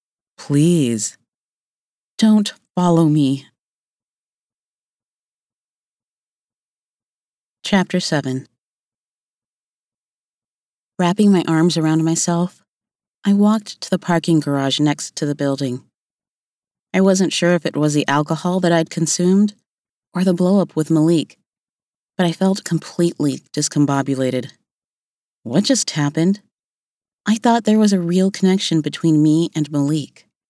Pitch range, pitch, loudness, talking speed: 150-185 Hz, 165 Hz, -17 LUFS, 110 wpm